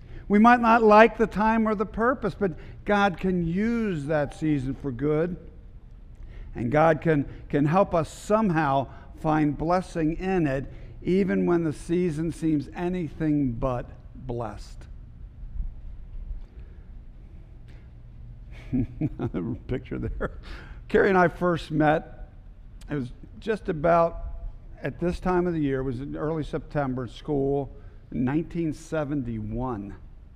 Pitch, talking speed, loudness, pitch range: 155 Hz, 120 wpm, -25 LUFS, 125-175 Hz